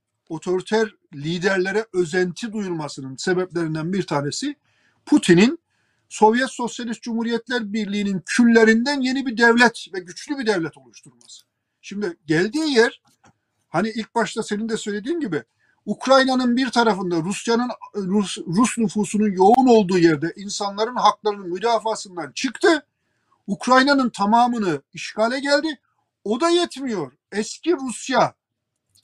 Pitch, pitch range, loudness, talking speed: 215 Hz, 180-245 Hz, -20 LUFS, 110 wpm